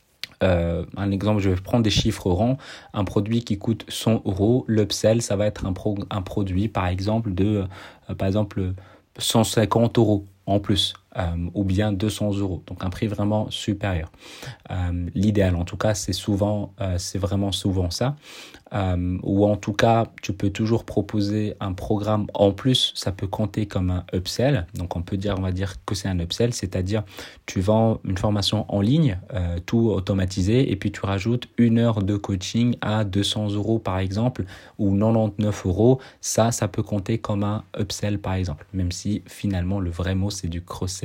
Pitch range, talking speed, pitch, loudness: 95-110 Hz, 190 wpm, 100 Hz, -23 LUFS